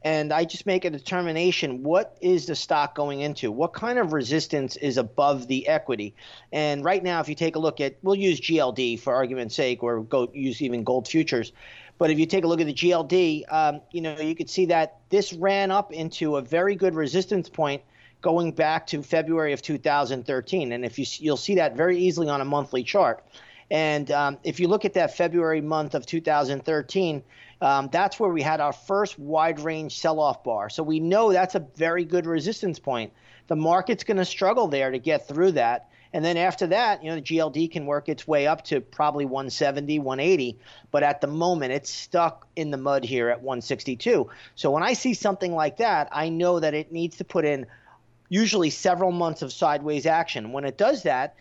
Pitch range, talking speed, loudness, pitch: 140-175 Hz, 210 wpm, -25 LUFS, 155 Hz